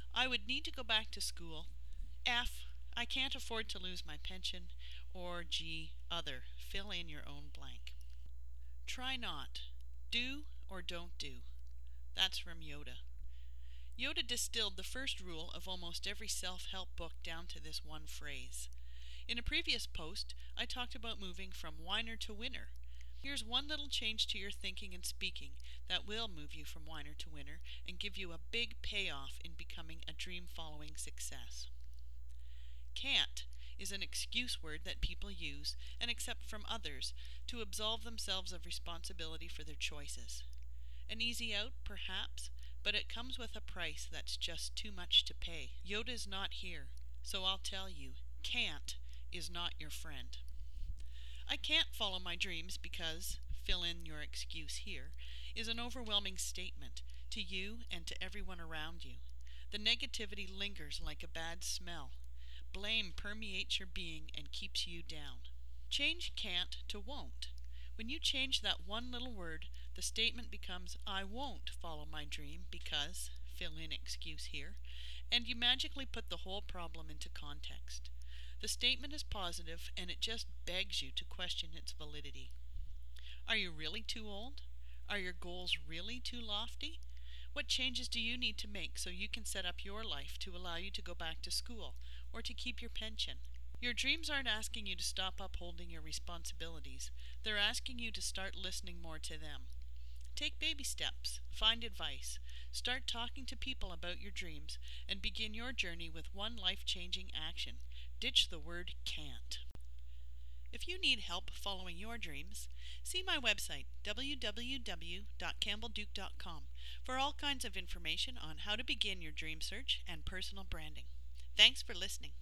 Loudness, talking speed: -41 LUFS, 160 wpm